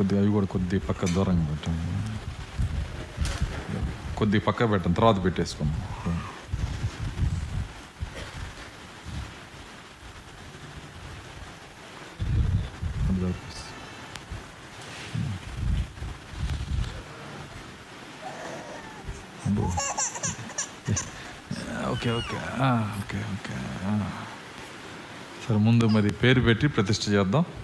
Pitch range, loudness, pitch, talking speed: 90-110 Hz, -28 LUFS, 100 Hz, 40 wpm